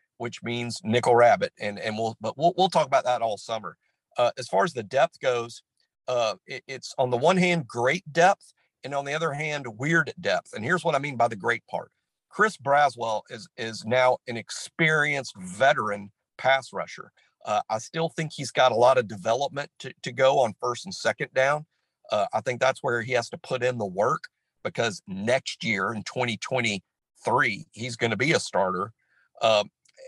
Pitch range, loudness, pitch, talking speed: 115-155 Hz, -25 LUFS, 130 Hz, 195 wpm